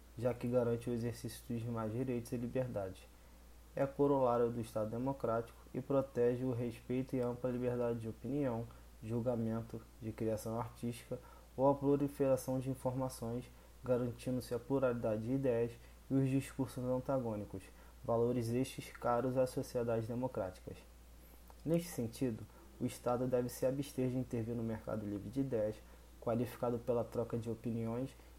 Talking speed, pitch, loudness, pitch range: 140 wpm, 120 Hz, -38 LUFS, 115-130 Hz